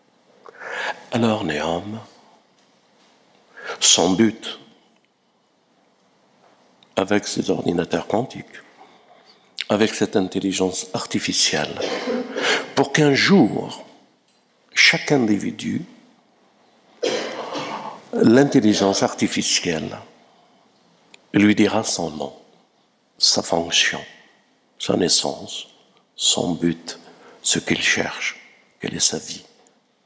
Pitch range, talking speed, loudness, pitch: 95-115 Hz, 70 wpm, -19 LUFS, 105 Hz